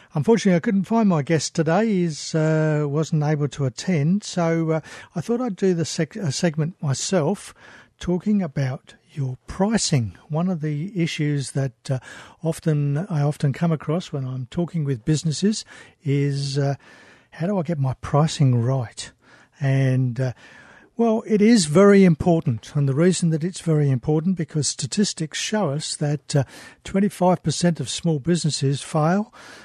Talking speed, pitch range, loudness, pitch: 160 wpm, 140-180 Hz, -22 LUFS, 160 Hz